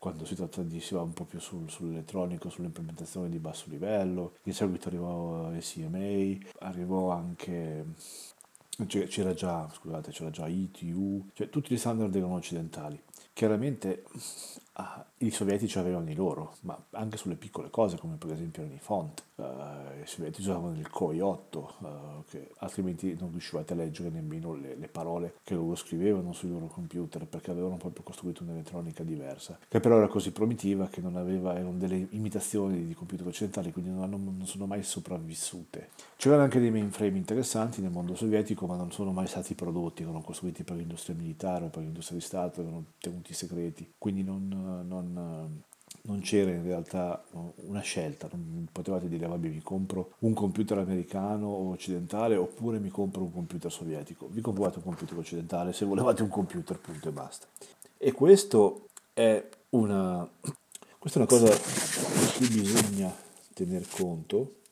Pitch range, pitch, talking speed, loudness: 85-100 Hz, 90 Hz, 165 wpm, -32 LUFS